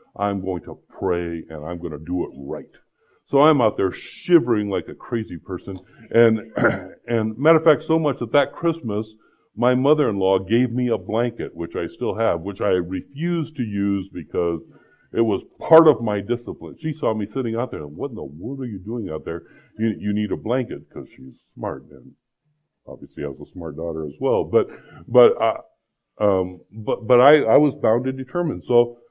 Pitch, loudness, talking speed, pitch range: 115 Hz, -21 LUFS, 200 wpm, 95-135 Hz